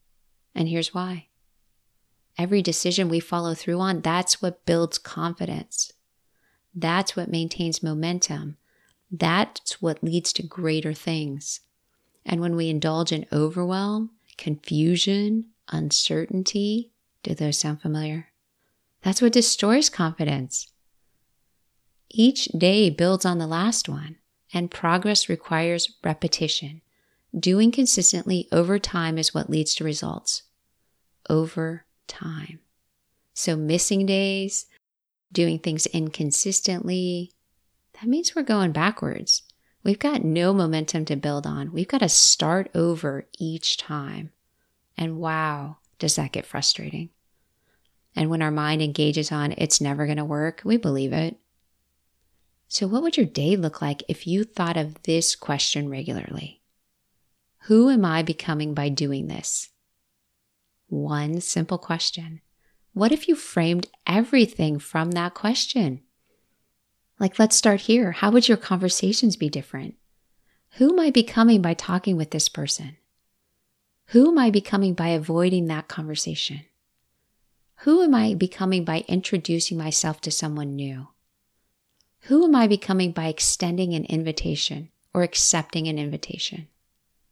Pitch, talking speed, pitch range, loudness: 165 Hz, 130 wpm, 155-195 Hz, -23 LUFS